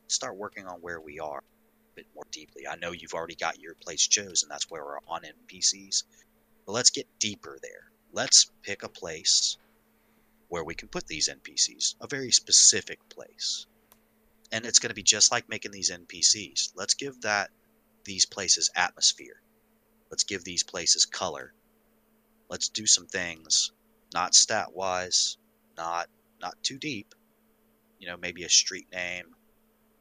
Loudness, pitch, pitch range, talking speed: -25 LUFS, 95 Hz, 90-135 Hz, 160 wpm